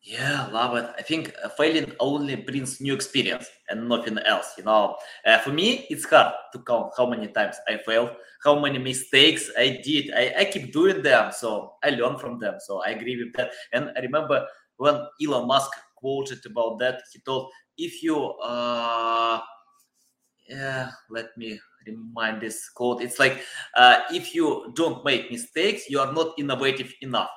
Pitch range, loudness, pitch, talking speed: 120-150 Hz, -24 LUFS, 130 Hz, 175 wpm